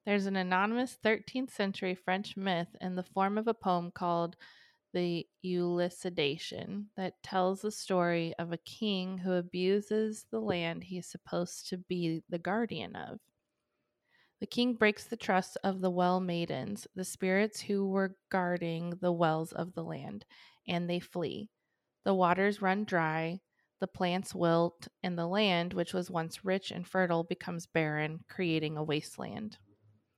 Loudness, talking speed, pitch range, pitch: -33 LUFS, 155 wpm, 170-200 Hz, 185 Hz